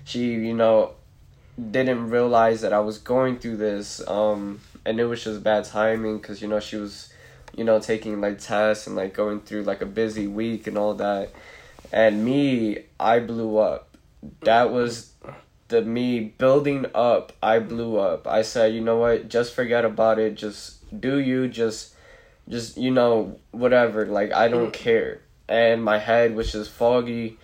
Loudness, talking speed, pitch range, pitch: -23 LUFS, 175 wpm, 105-120 Hz, 110 Hz